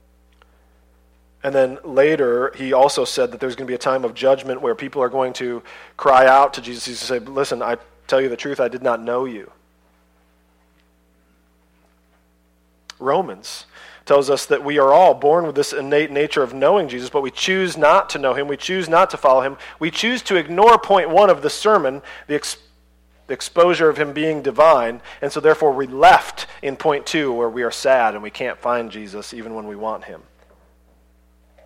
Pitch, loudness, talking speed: 130 Hz, -18 LUFS, 195 wpm